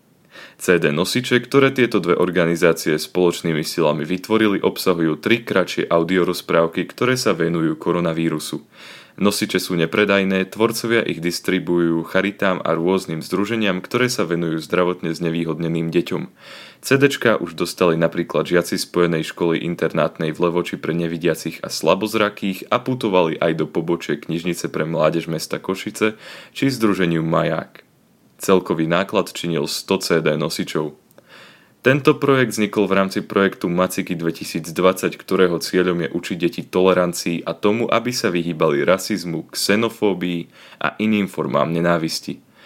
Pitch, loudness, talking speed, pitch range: 90 Hz, -19 LUFS, 130 wpm, 85-105 Hz